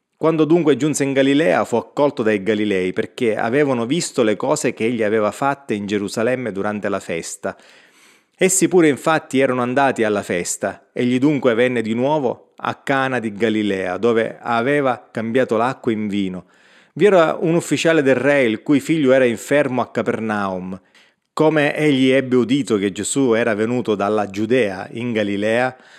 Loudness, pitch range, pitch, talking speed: -18 LUFS, 110-140 Hz, 125 Hz, 160 wpm